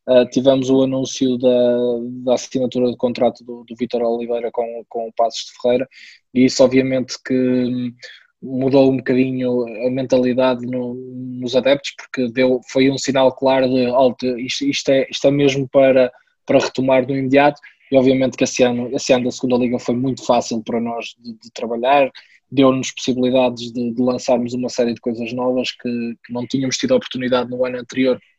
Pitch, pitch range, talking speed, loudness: 125 Hz, 125-130 Hz, 185 wpm, -18 LUFS